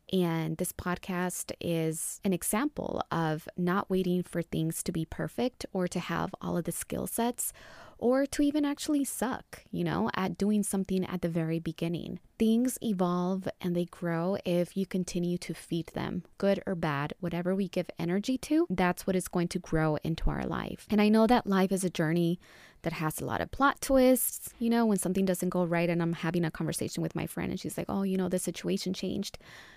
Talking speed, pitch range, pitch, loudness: 210 wpm, 170-200 Hz, 180 Hz, -31 LUFS